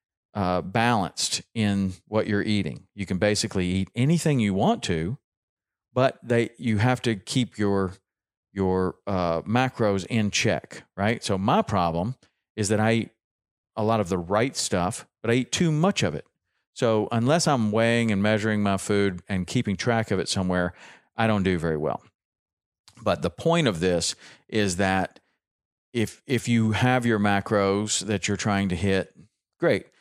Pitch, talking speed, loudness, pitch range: 105 Hz, 170 wpm, -25 LUFS, 95-115 Hz